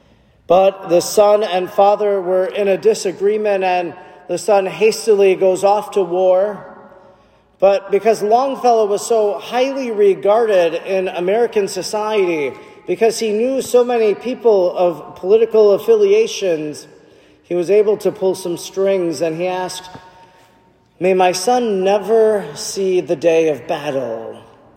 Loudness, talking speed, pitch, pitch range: -16 LUFS, 135 wpm, 195 Hz, 185-215 Hz